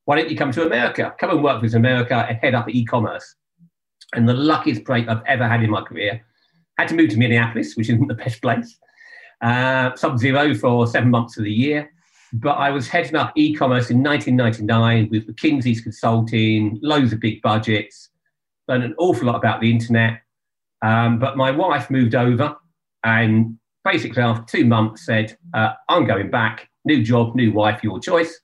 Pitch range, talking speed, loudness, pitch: 115-145 Hz, 190 wpm, -19 LUFS, 120 Hz